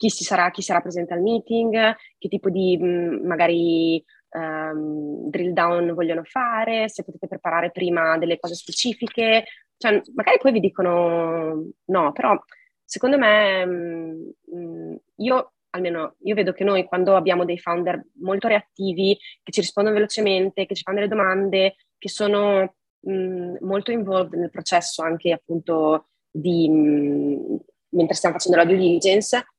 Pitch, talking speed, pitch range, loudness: 185 Hz, 145 wpm, 170-205 Hz, -21 LUFS